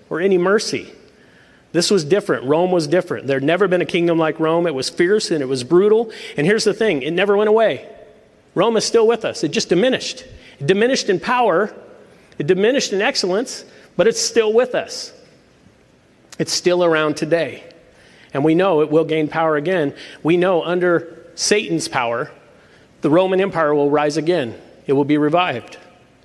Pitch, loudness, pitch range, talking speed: 175 Hz, -17 LUFS, 155-205 Hz, 185 wpm